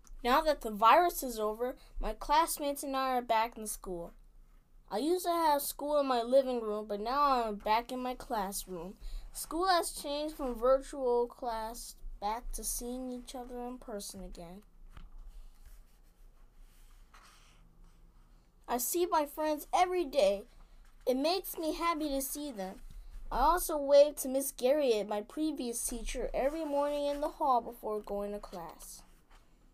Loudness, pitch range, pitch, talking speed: -32 LUFS, 220-295 Hz, 255 Hz, 150 wpm